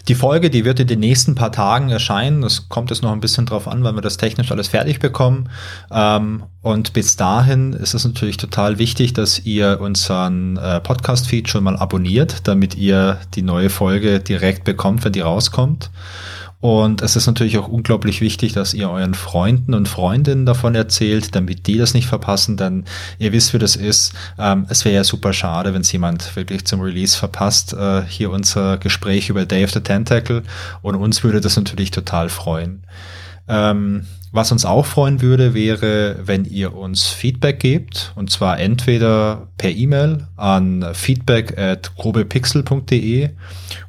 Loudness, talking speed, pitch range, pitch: -16 LUFS, 170 wpm, 95-115 Hz, 105 Hz